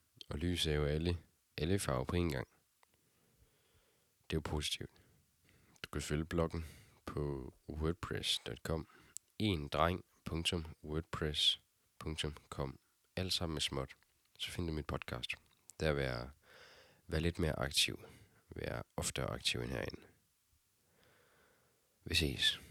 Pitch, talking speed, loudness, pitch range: 80 Hz, 115 wpm, -38 LUFS, 75-90 Hz